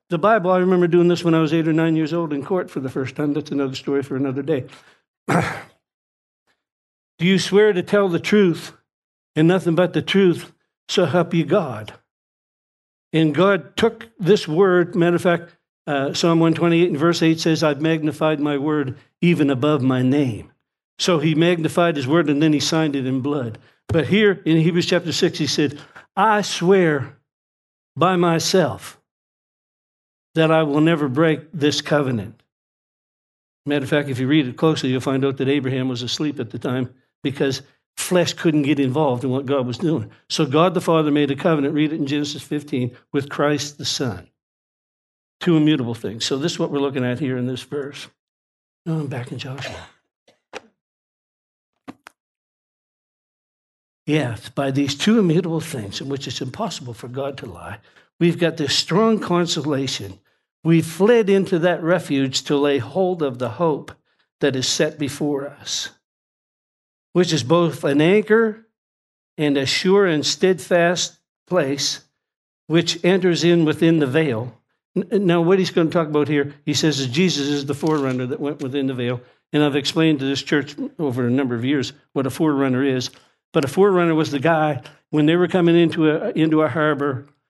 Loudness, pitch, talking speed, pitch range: -19 LUFS, 150 Hz, 180 wpm, 140-170 Hz